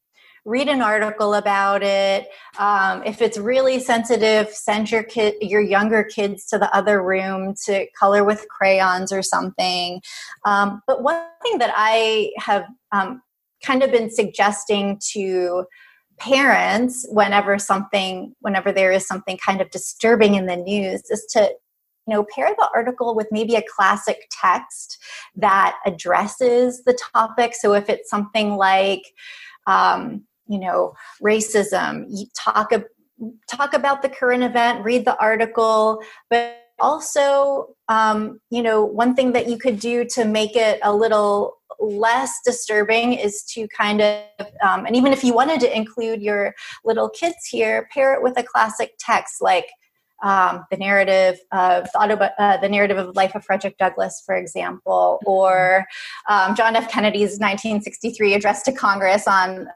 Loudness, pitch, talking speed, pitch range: -19 LUFS, 215 Hz, 155 wpm, 200-240 Hz